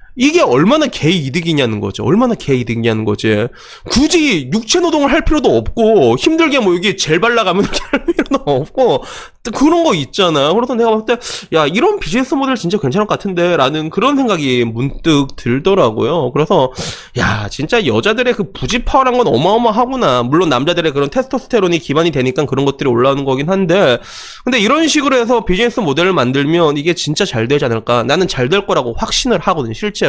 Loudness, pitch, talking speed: -13 LUFS, 195 Hz, 405 characters per minute